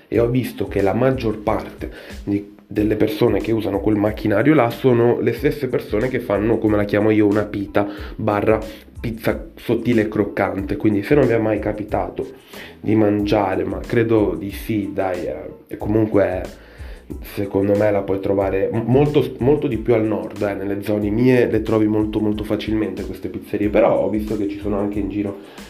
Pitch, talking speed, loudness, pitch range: 105 Hz, 185 wpm, -19 LUFS, 100-110 Hz